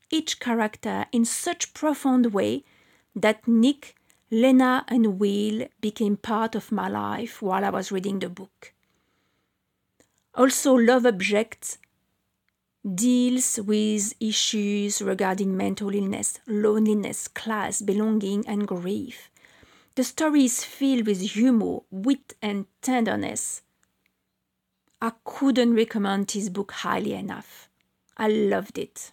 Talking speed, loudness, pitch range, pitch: 115 wpm, -24 LUFS, 205-250 Hz, 220 Hz